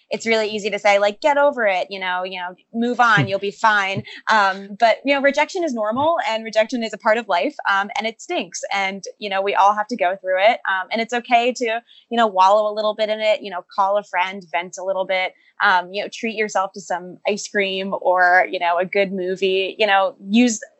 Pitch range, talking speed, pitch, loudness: 190-230 Hz, 250 wpm, 205 Hz, -19 LUFS